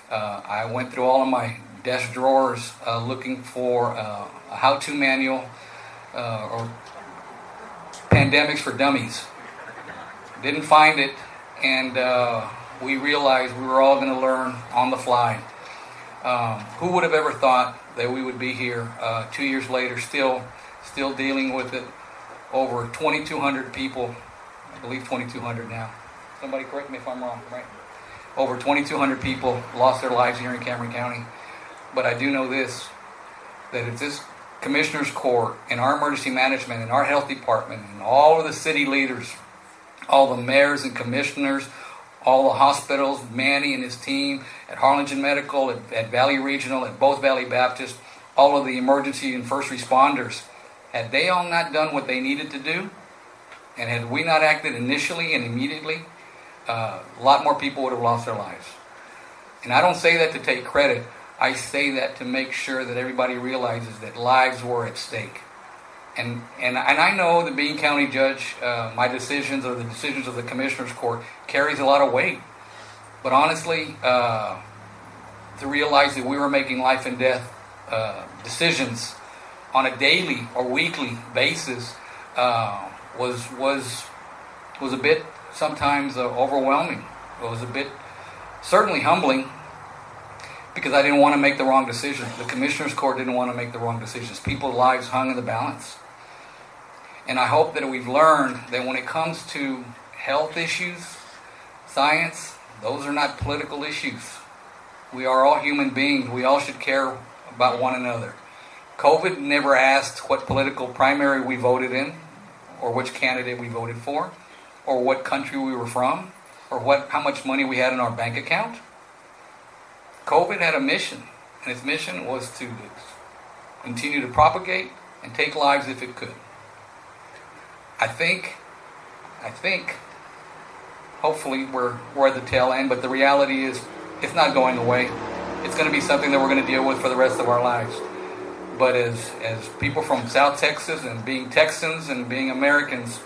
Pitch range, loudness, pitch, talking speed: 125-140 Hz, -22 LUFS, 130 Hz, 165 wpm